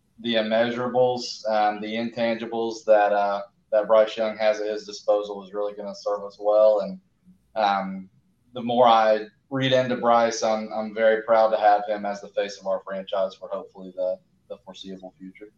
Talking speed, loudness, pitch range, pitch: 185 wpm, -23 LUFS, 100-115 Hz, 105 Hz